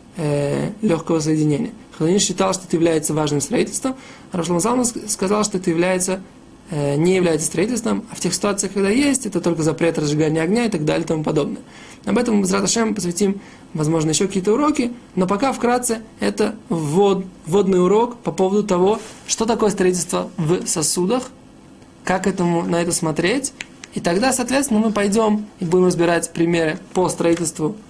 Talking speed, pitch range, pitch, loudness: 165 wpm, 170-220 Hz, 190 Hz, -19 LUFS